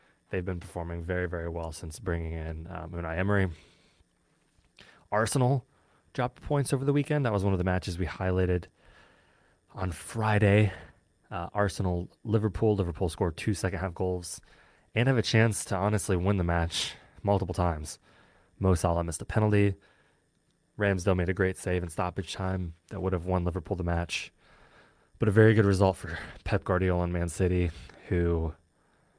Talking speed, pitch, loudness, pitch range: 160 wpm, 95 Hz, -29 LUFS, 85-100 Hz